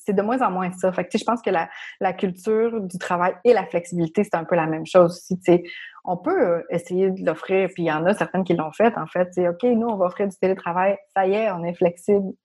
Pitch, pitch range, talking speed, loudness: 185 Hz, 175-205 Hz, 270 wpm, -22 LUFS